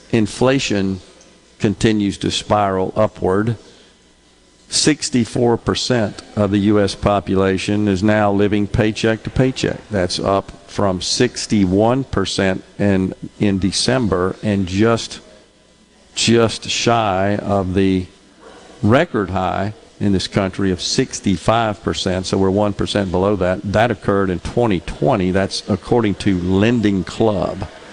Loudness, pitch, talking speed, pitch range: -17 LUFS, 100 Hz, 105 wpm, 95-110 Hz